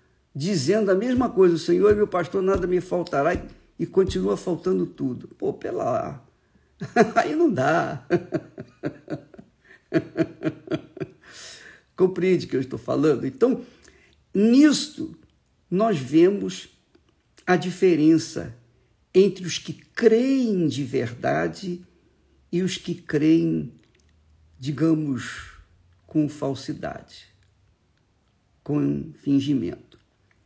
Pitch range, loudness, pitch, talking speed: 115-190 Hz, -23 LUFS, 165 Hz, 95 wpm